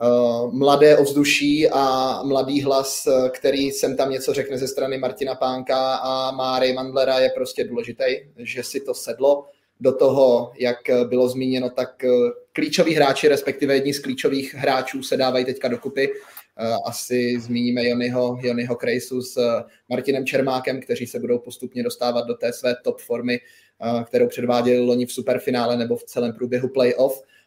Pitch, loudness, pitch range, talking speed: 130 Hz, -21 LUFS, 125-135 Hz, 150 wpm